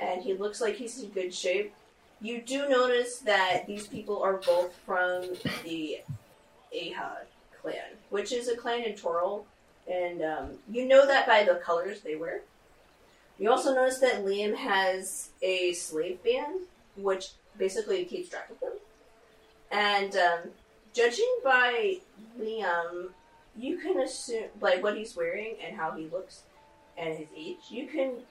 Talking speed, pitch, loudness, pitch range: 155 wpm, 215 Hz, -29 LUFS, 180-260 Hz